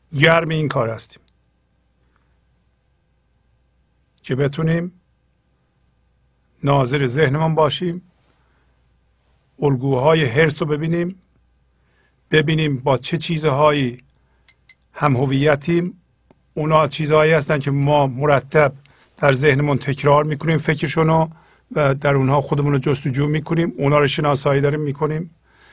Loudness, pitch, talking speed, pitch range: -18 LUFS, 145 Hz, 100 wpm, 130-155 Hz